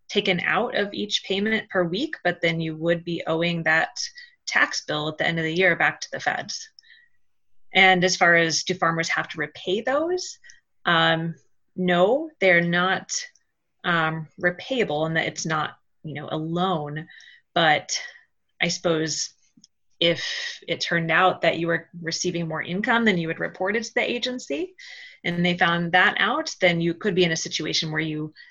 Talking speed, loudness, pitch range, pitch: 175 wpm, -23 LUFS, 165-230 Hz, 180 Hz